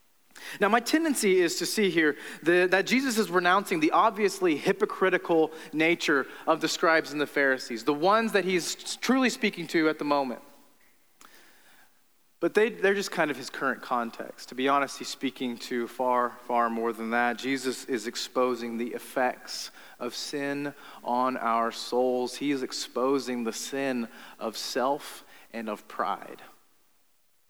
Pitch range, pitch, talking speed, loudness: 125-185 Hz, 145 Hz, 155 wpm, -27 LUFS